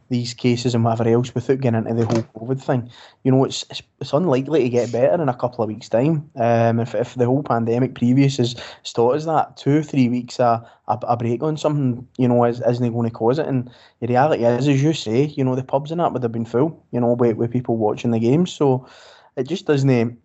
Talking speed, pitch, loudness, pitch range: 250 wpm, 125 Hz, -20 LUFS, 115-135 Hz